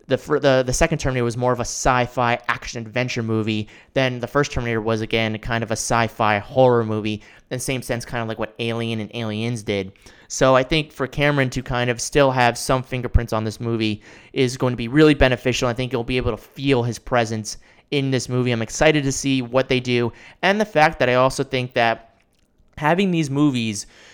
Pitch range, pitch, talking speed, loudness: 115-130 Hz, 125 Hz, 225 wpm, -21 LUFS